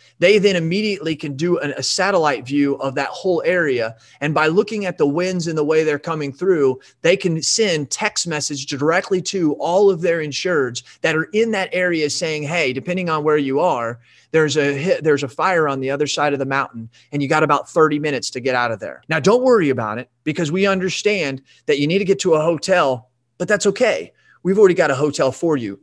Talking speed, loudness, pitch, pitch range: 230 wpm, -18 LUFS, 155 Hz, 140-180 Hz